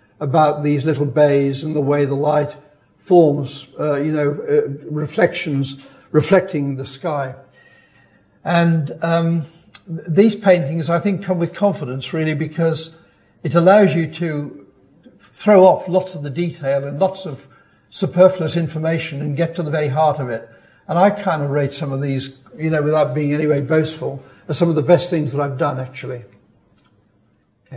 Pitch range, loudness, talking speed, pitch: 145-170 Hz, -18 LUFS, 160 wpm, 150 Hz